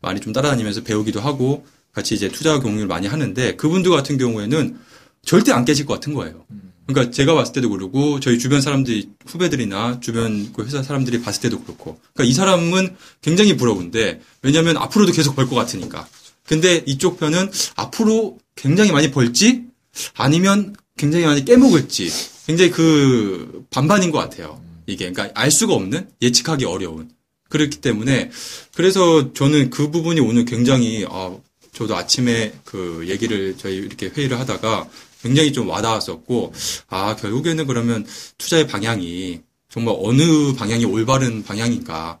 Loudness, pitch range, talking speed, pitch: -18 LUFS, 110-155 Hz, 365 characters per minute, 130 Hz